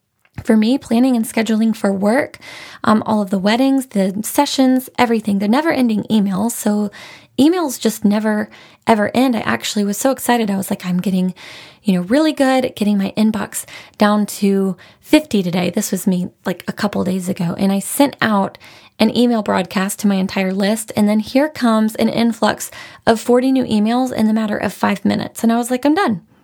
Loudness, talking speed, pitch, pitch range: -17 LUFS, 195 wpm, 215 Hz, 200-245 Hz